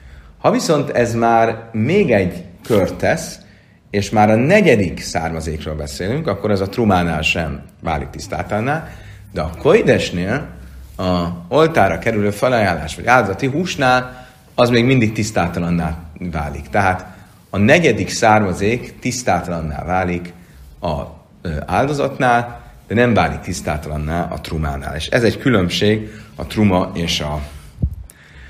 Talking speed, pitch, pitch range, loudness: 120 wpm, 95 Hz, 80-110 Hz, -17 LUFS